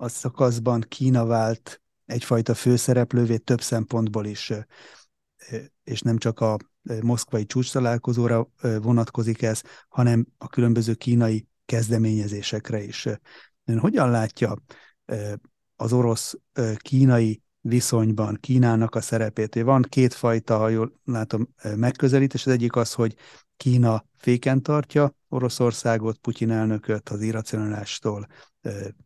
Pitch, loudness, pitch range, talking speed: 115 Hz, -23 LUFS, 110-125 Hz, 105 wpm